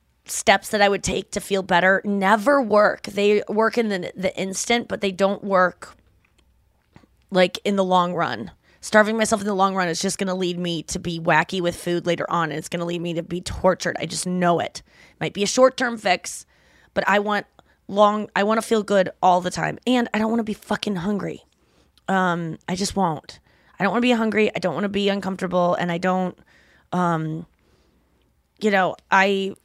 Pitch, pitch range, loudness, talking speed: 190 Hz, 175-205 Hz, -21 LUFS, 215 wpm